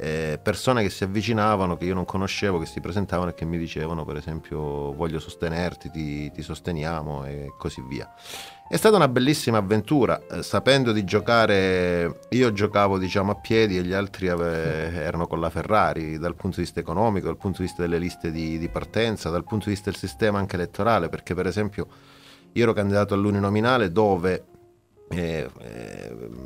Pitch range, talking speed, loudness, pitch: 85-105 Hz, 175 wpm, -24 LUFS, 90 Hz